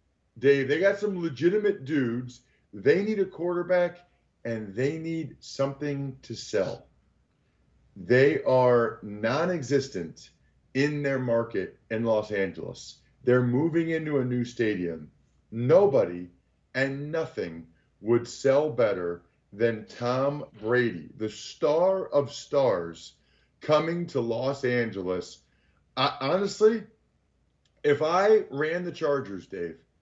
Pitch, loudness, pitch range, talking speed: 130 Hz, -27 LUFS, 105-155 Hz, 115 wpm